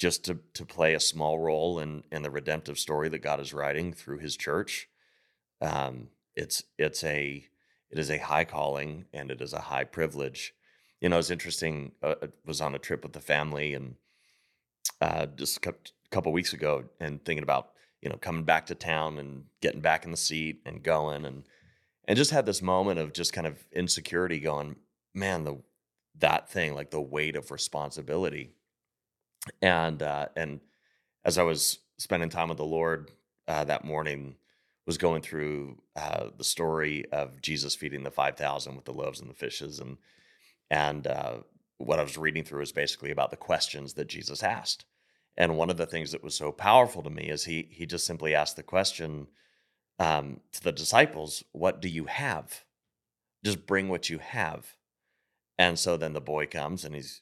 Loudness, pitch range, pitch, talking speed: -30 LUFS, 75-80 Hz, 75 Hz, 190 wpm